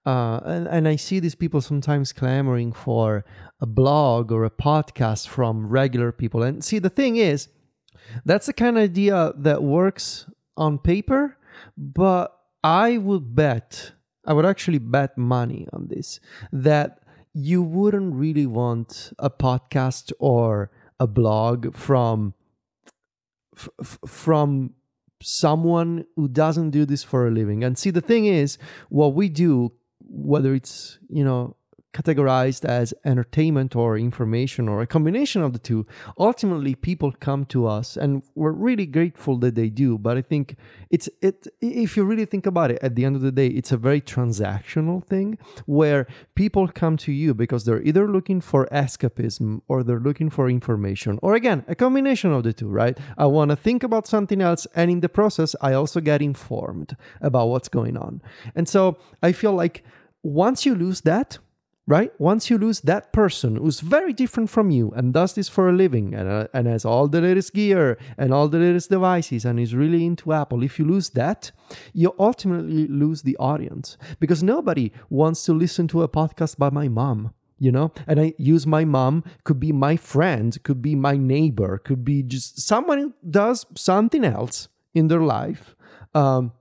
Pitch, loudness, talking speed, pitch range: 145 Hz, -21 LUFS, 175 wpm, 125-175 Hz